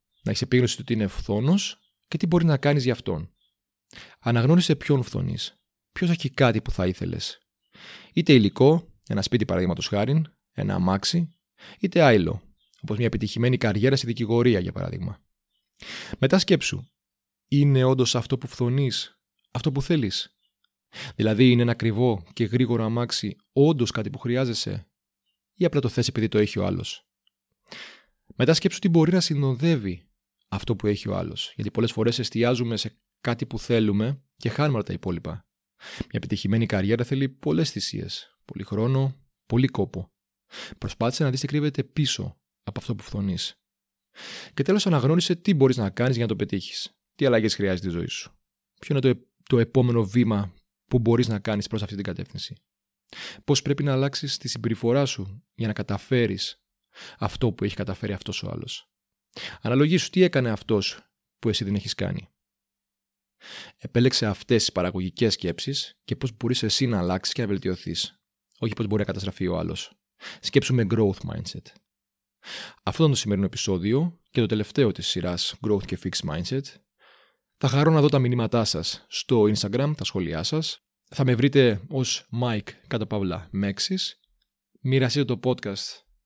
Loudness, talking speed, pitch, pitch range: -24 LUFS, 160 wpm, 115 Hz, 100-135 Hz